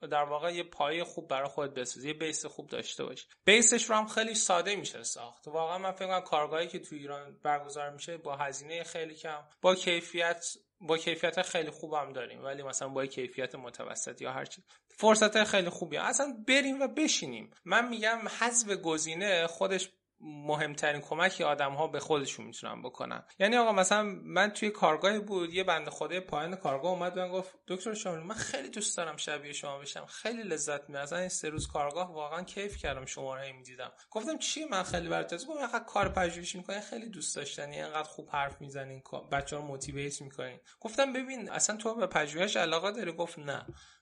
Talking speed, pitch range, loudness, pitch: 190 wpm, 145-200 Hz, -32 LUFS, 170 Hz